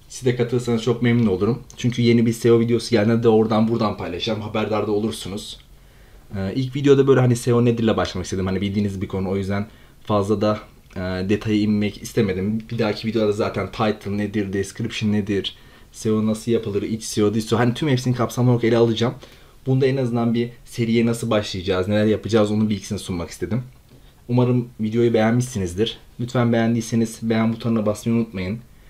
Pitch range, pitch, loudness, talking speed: 105-120 Hz, 110 Hz, -21 LUFS, 175 wpm